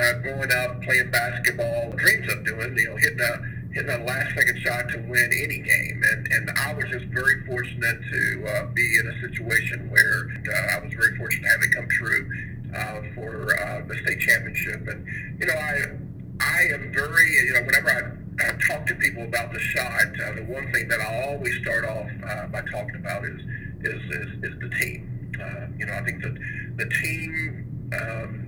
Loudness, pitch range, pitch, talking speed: -23 LUFS, 115-130 Hz, 120 Hz, 195 wpm